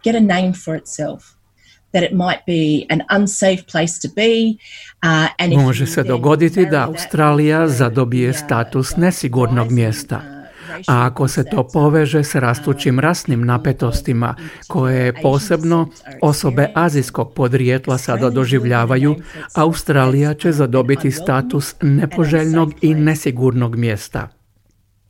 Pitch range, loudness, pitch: 130-160 Hz, -16 LUFS, 145 Hz